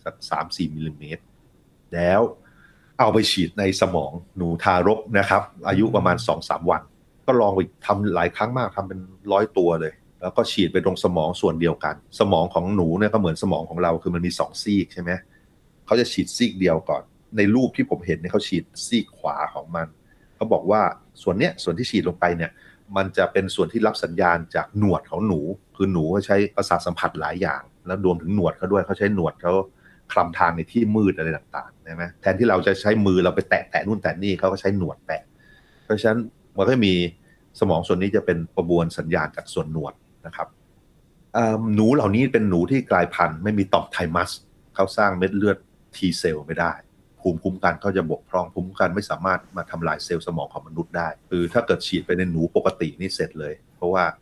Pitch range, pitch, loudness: 85-100 Hz, 95 Hz, -22 LUFS